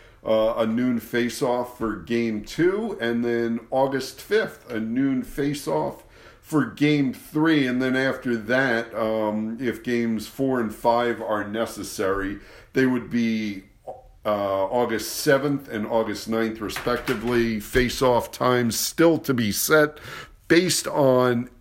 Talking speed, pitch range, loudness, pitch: 140 wpm, 110-135 Hz, -23 LUFS, 120 Hz